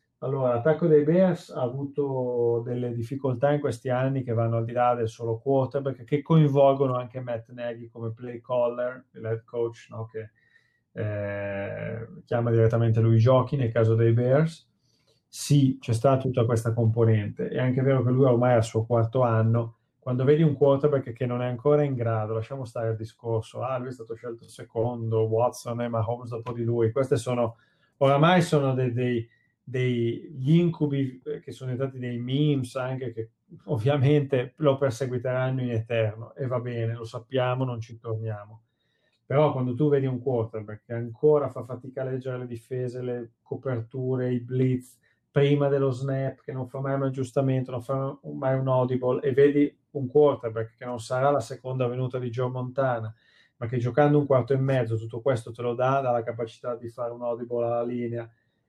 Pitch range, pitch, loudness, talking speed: 115-135 Hz, 125 Hz, -26 LUFS, 180 wpm